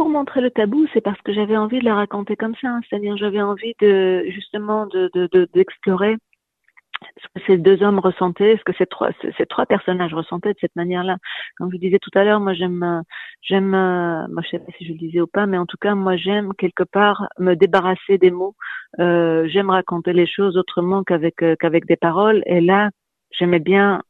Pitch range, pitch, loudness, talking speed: 175-205 Hz, 190 Hz, -18 LUFS, 220 wpm